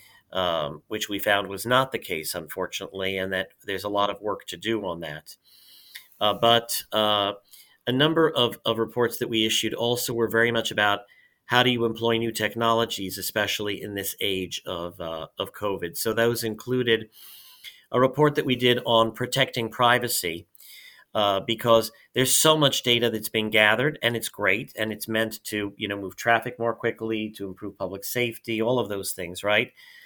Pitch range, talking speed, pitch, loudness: 100-120 Hz, 185 wpm, 115 Hz, -24 LUFS